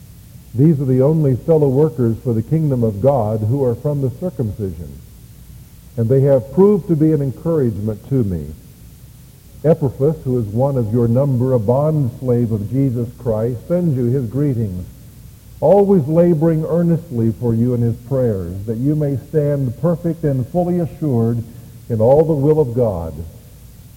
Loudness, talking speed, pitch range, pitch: -17 LUFS, 165 wpm, 115-150 Hz, 130 Hz